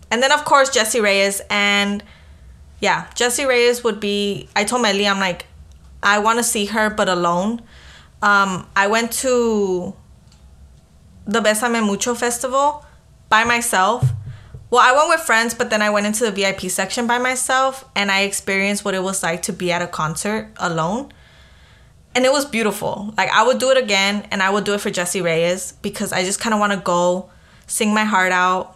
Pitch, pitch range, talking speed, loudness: 205 Hz, 185-235 Hz, 190 wpm, -18 LUFS